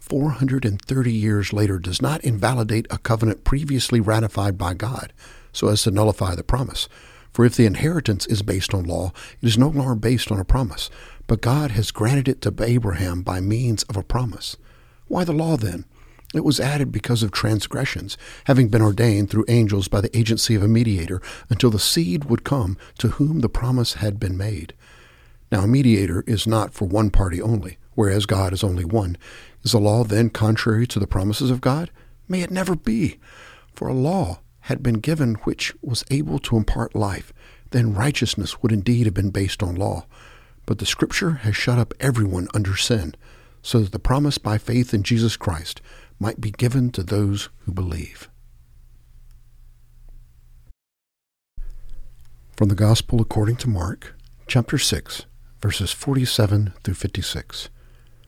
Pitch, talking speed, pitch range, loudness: 110 Hz, 175 wpm, 95-120 Hz, -21 LUFS